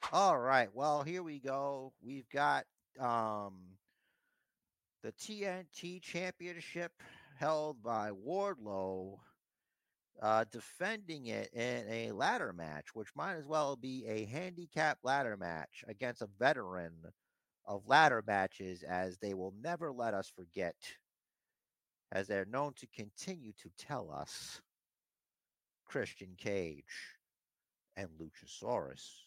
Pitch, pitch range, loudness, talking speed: 125 Hz, 100-155 Hz, -38 LUFS, 115 wpm